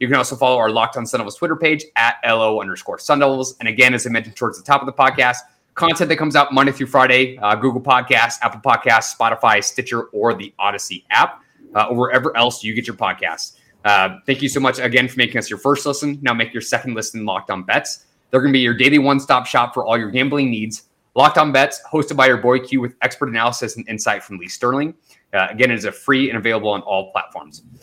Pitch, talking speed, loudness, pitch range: 125 Hz, 240 wpm, -17 LUFS, 115-140 Hz